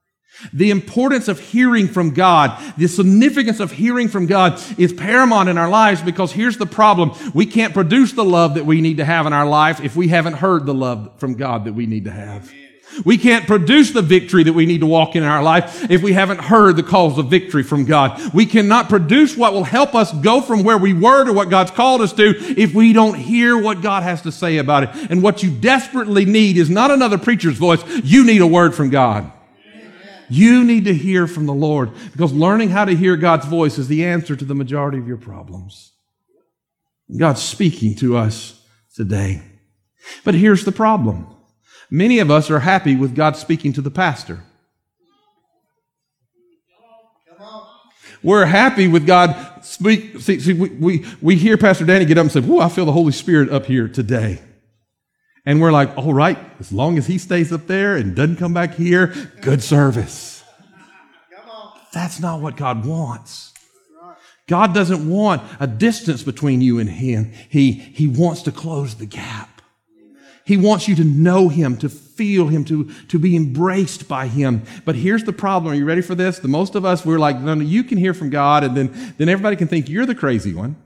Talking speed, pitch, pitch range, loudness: 205 wpm, 170 Hz, 145-205 Hz, -15 LUFS